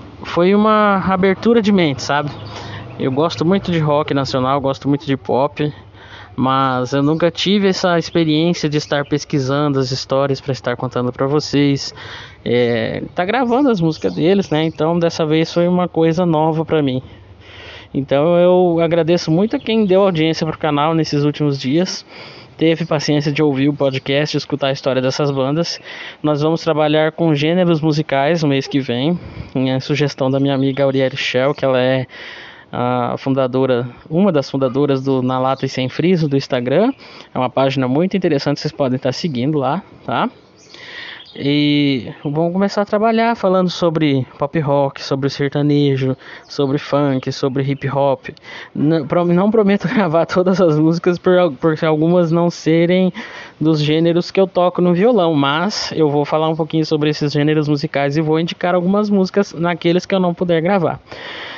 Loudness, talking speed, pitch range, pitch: -16 LUFS, 170 wpm, 135-175 Hz, 150 Hz